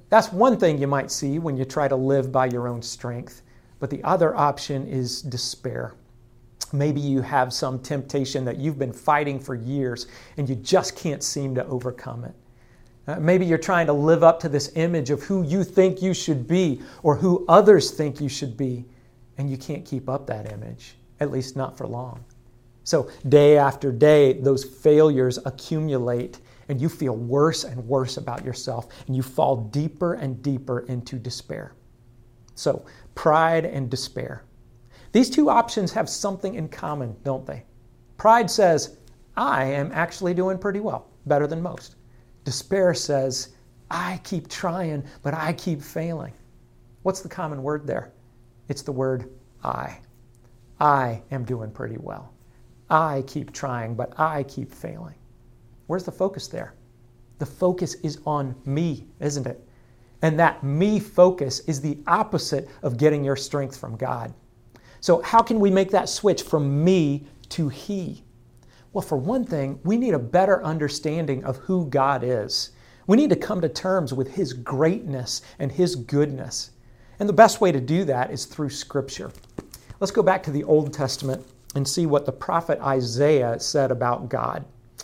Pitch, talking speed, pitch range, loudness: 140 Hz, 170 wpm, 125-160 Hz, -23 LUFS